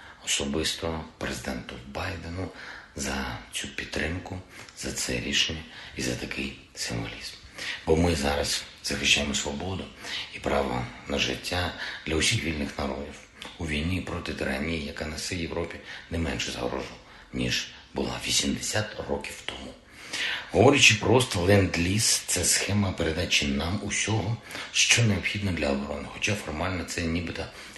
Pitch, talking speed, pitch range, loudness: 80 Hz, 120 wpm, 70-95 Hz, -27 LUFS